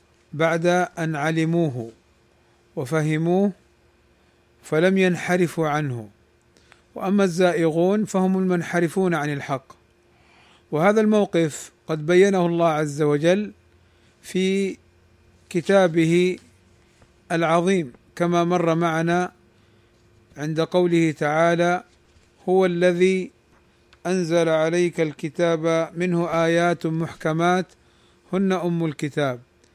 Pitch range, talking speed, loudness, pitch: 150-180 Hz, 80 wpm, -21 LUFS, 165 Hz